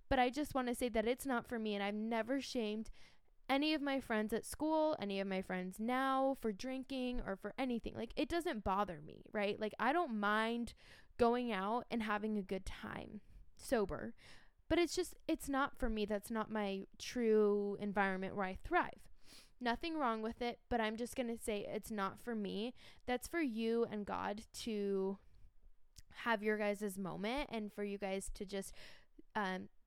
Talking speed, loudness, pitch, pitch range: 190 wpm, -40 LUFS, 220 Hz, 205-250 Hz